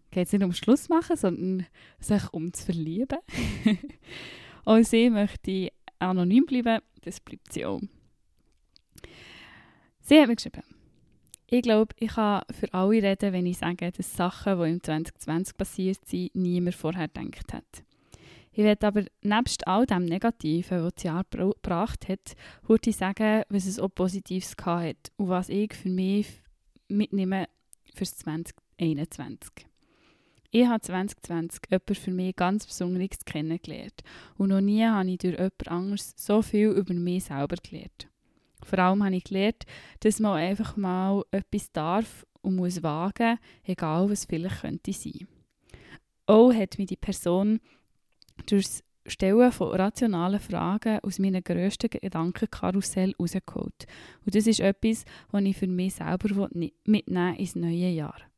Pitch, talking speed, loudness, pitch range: 195 Hz, 150 wpm, -27 LUFS, 180-215 Hz